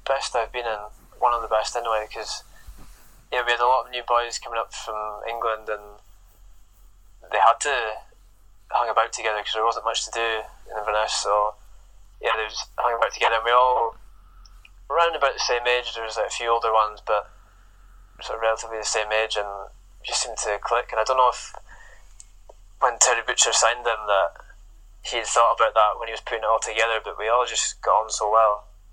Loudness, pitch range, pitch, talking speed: -23 LUFS, 105-115 Hz, 110 Hz, 215 wpm